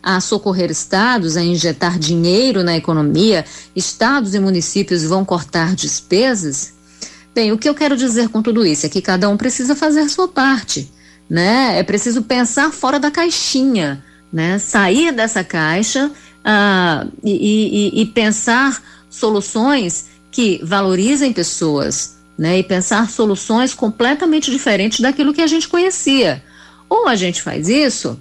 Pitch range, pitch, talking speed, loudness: 175-260 Hz, 210 Hz, 145 wpm, -15 LUFS